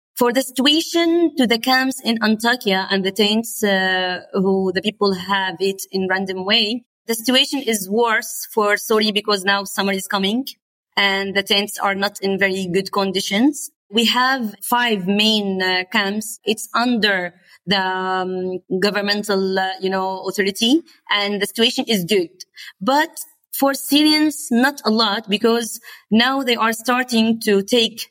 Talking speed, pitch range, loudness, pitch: 155 wpm, 195-240 Hz, -18 LUFS, 215 Hz